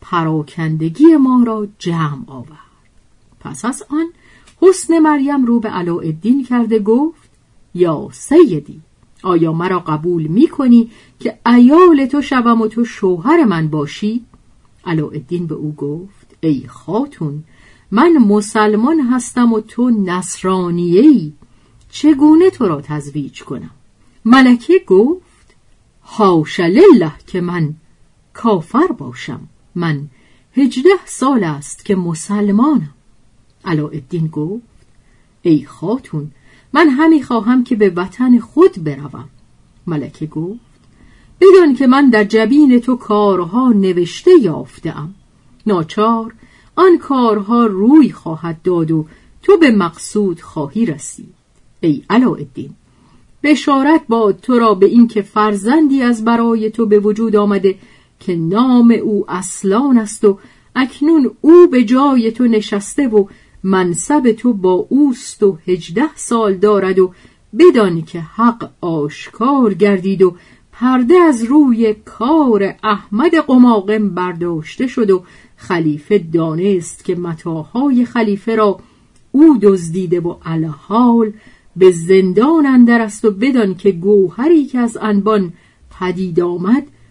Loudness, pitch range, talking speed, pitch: -13 LUFS, 175-255 Hz, 120 wpm, 210 Hz